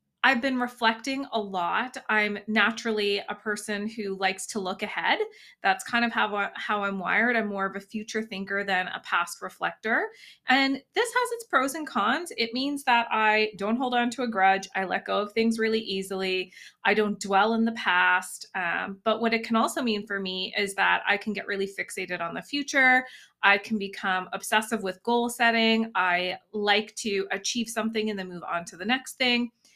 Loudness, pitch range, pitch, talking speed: -26 LUFS, 195-240 Hz, 215 Hz, 200 wpm